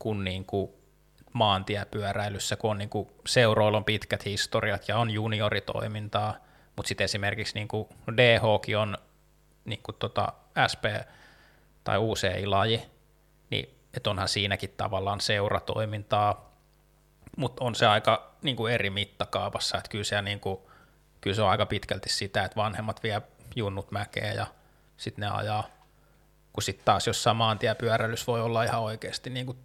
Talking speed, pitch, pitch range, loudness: 130 wpm, 105 Hz, 100-115 Hz, -28 LUFS